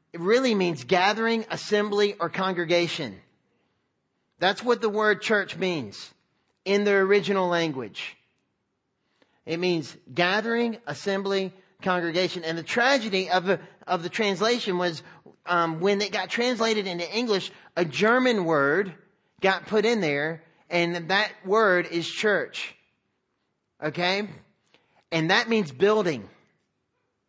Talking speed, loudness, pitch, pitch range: 120 wpm, -25 LUFS, 190 Hz, 170-210 Hz